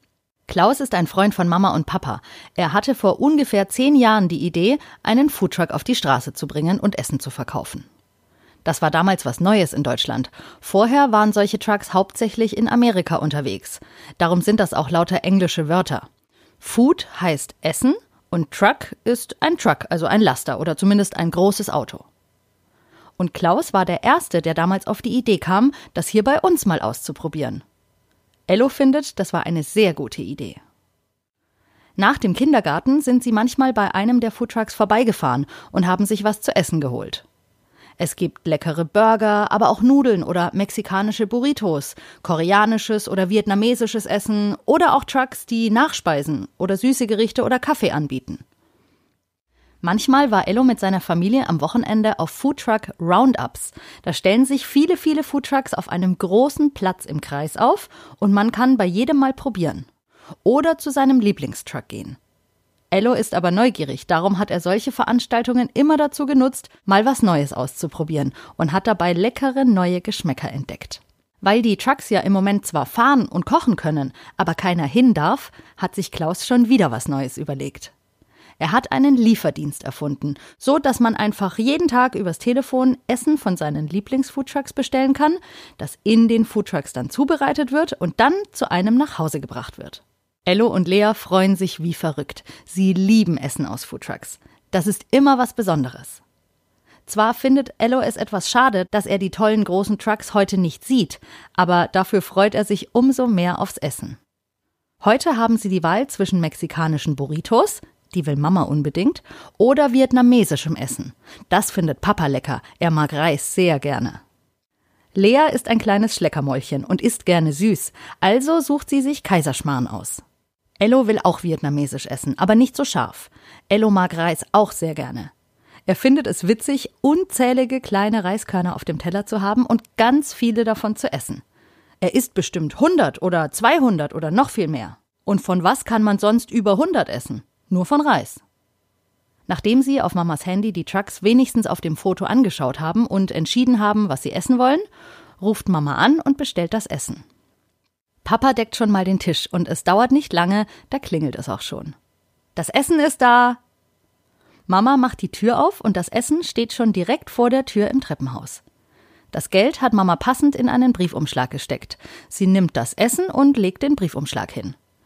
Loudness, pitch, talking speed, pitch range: -19 LUFS, 200 Hz, 170 wpm, 165-245 Hz